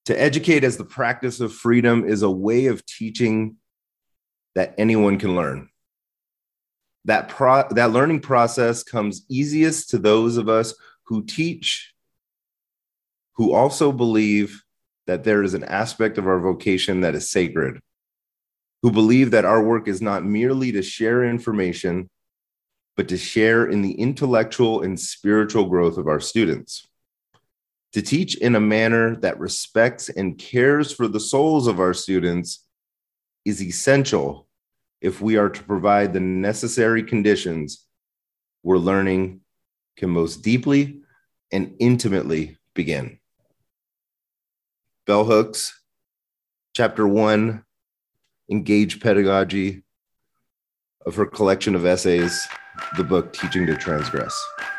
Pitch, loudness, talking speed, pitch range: 110 Hz, -20 LUFS, 125 wpm, 95-120 Hz